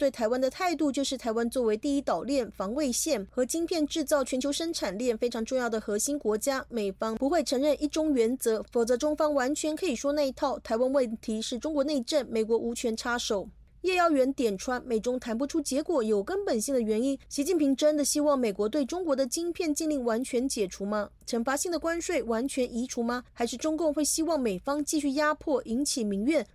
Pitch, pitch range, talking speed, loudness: 265 Hz, 235-300 Hz, 325 characters per minute, -29 LUFS